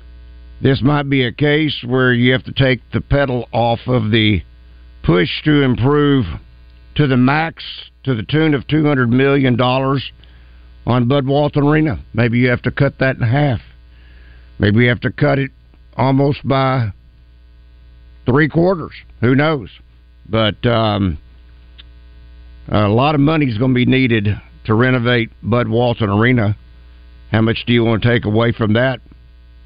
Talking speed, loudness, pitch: 155 wpm, -15 LUFS, 115 Hz